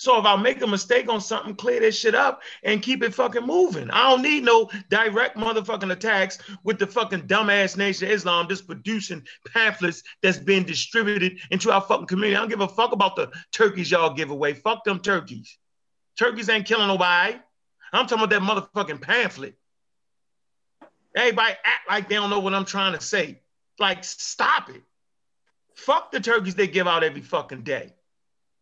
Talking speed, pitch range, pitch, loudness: 185 wpm, 190-230 Hz, 205 Hz, -22 LUFS